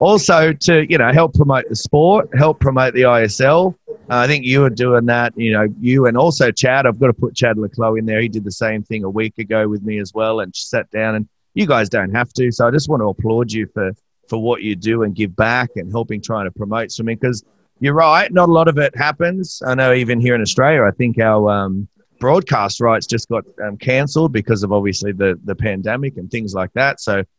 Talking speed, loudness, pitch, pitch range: 245 wpm, -16 LUFS, 115 Hz, 110-135 Hz